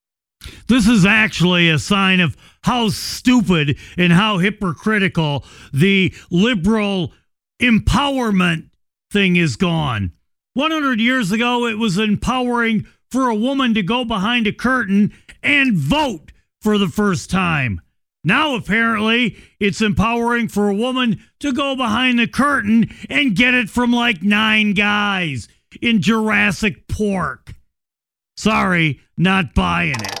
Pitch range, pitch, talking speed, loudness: 180-235 Hz, 210 Hz, 125 wpm, -16 LUFS